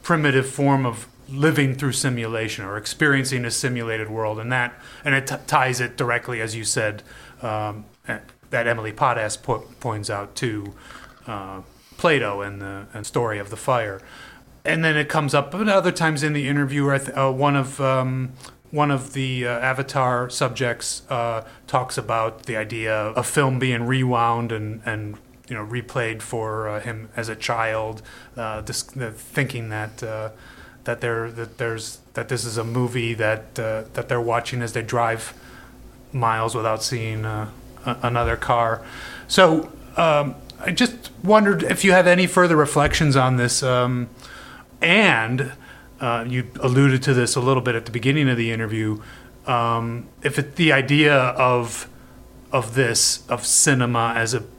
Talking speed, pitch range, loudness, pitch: 165 wpm, 115-135 Hz, -21 LUFS, 125 Hz